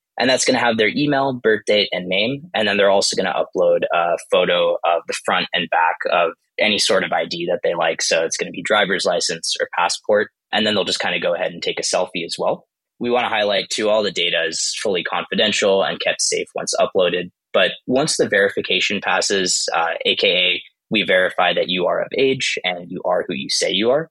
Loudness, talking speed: -18 LUFS, 235 wpm